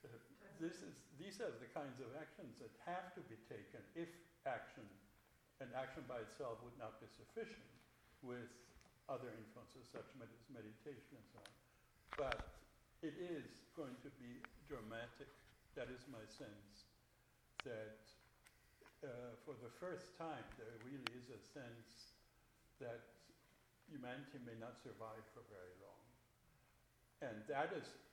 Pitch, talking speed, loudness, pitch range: 125 Hz, 140 wpm, -54 LUFS, 115-145 Hz